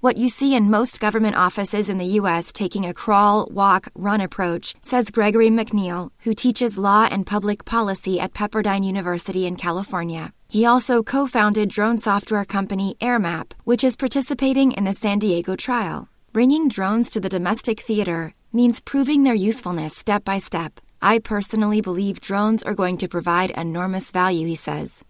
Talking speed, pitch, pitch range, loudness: 170 wpm, 205 Hz, 185-230 Hz, -20 LUFS